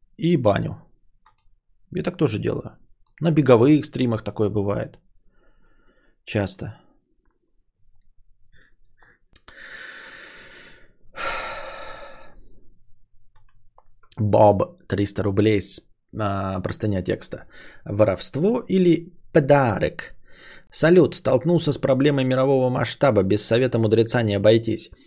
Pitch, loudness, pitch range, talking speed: 110 Hz, -21 LUFS, 100-135 Hz, 80 wpm